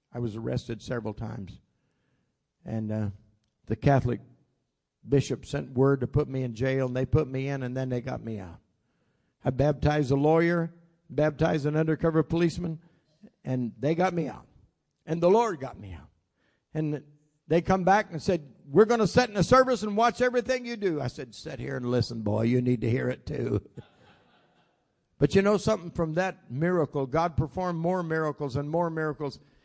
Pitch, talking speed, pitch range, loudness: 150 Hz, 185 wpm, 125-170 Hz, -27 LUFS